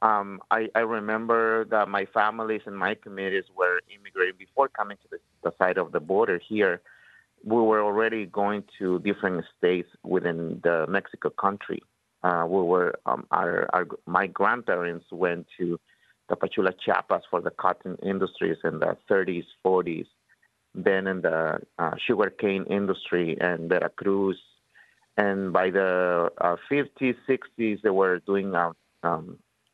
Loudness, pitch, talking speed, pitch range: -26 LUFS, 95 Hz, 150 wpm, 90-110 Hz